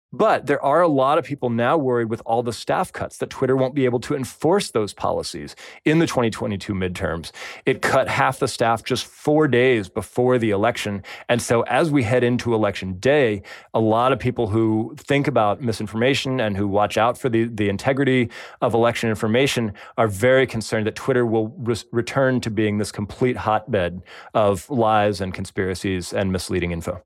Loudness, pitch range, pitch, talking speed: -21 LUFS, 105-125 Hz, 115 Hz, 190 wpm